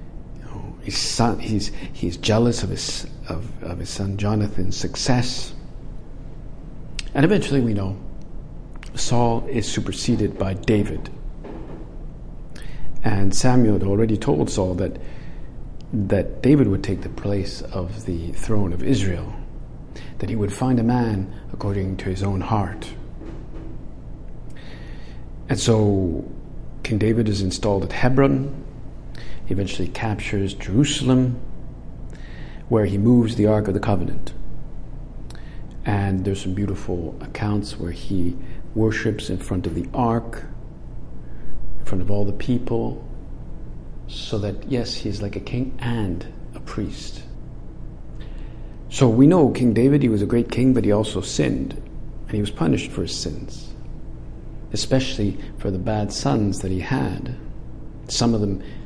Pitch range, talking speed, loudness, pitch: 95-120 Hz, 135 wpm, -22 LUFS, 105 Hz